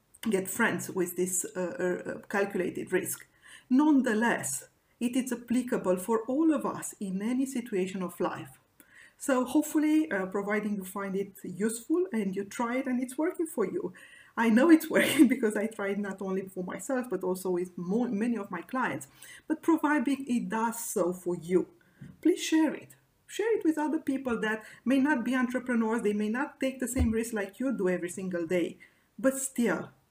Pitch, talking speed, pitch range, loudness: 230 Hz, 185 wpm, 195-265 Hz, -30 LUFS